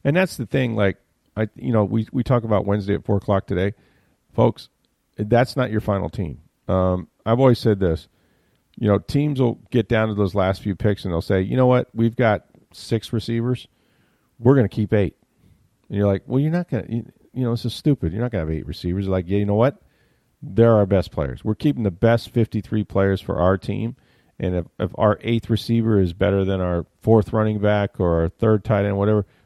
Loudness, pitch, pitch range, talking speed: -21 LUFS, 105 Hz, 95-115 Hz, 225 wpm